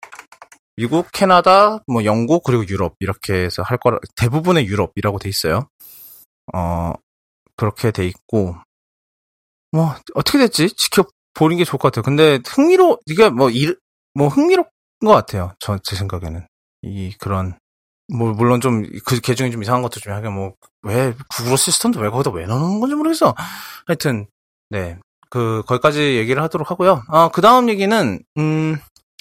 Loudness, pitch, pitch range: -17 LUFS, 125 Hz, 100-165 Hz